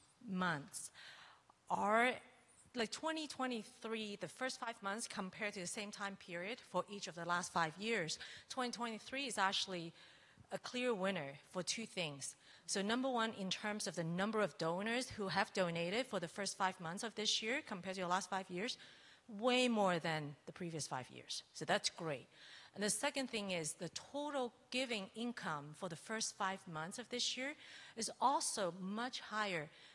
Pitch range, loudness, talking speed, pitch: 180-235 Hz, -41 LUFS, 175 wpm, 200 Hz